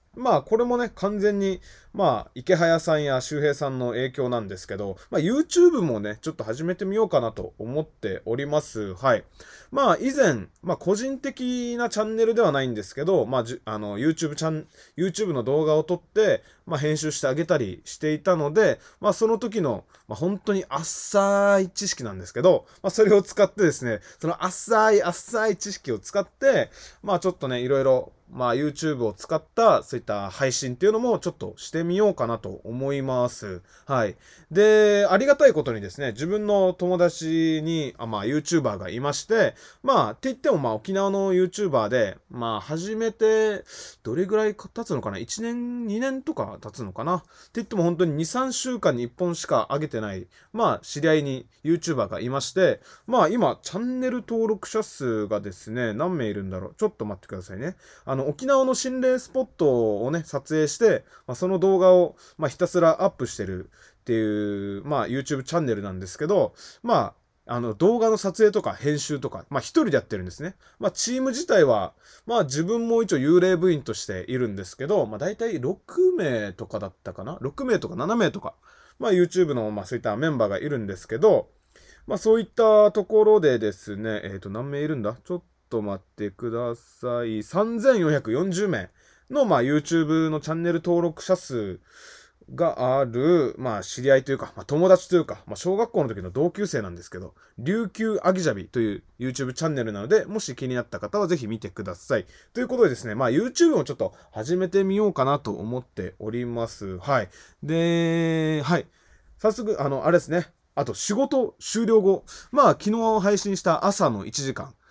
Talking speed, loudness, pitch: 400 characters per minute, -24 LUFS, 165 Hz